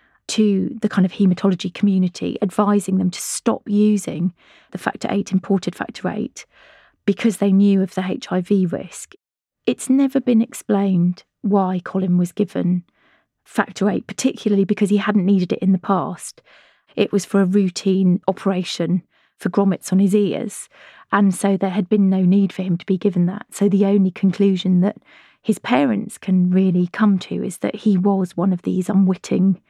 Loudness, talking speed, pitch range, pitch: -19 LUFS, 175 wpm, 185-205 Hz, 195 Hz